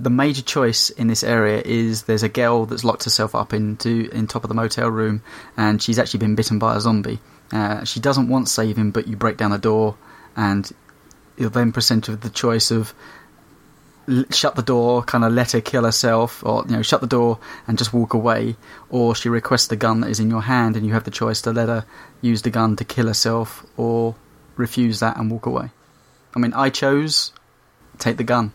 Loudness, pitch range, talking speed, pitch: -19 LUFS, 110-120 Hz, 225 wpm, 115 Hz